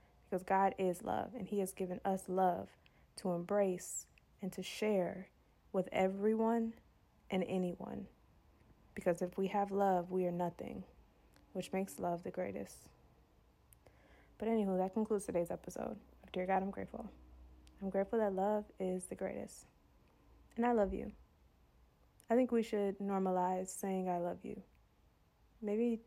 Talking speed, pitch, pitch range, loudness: 145 wpm, 190 Hz, 180-205 Hz, -38 LUFS